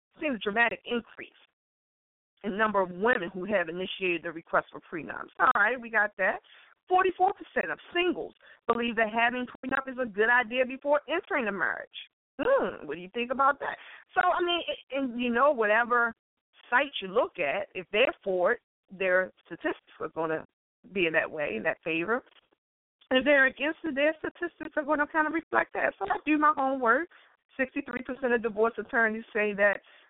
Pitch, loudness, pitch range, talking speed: 250 Hz, -28 LUFS, 210-300 Hz, 190 wpm